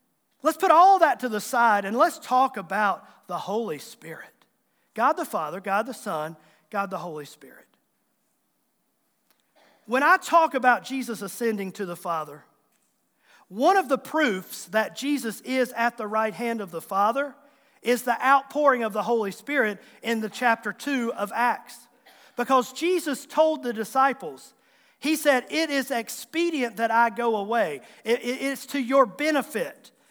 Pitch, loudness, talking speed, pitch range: 240 Hz, -24 LUFS, 160 wpm, 210-280 Hz